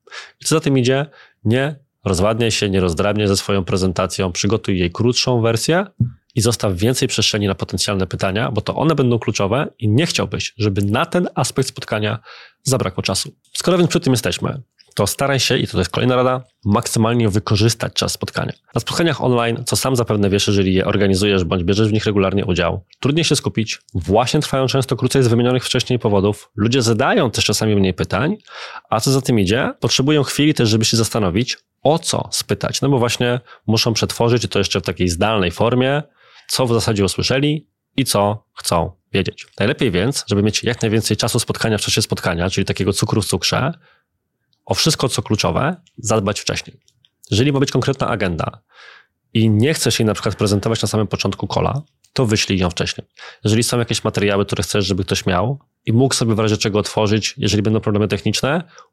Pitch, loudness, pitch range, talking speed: 115 Hz, -18 LUFS, 100-130 Hz, 185 wpm